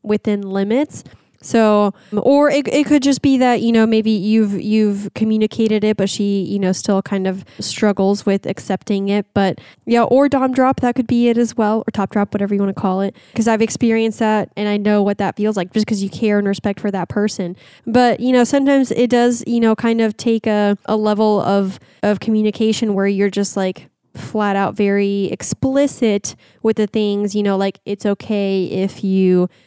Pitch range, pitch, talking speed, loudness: 200-225 Hz, 210 Hz, 210 wpm, -17 LUFS